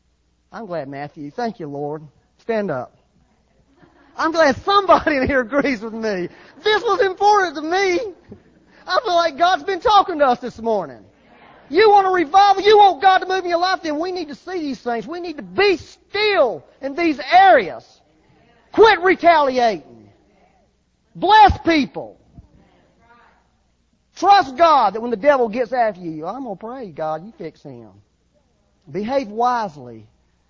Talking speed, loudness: 155 wpm, -17 LUFS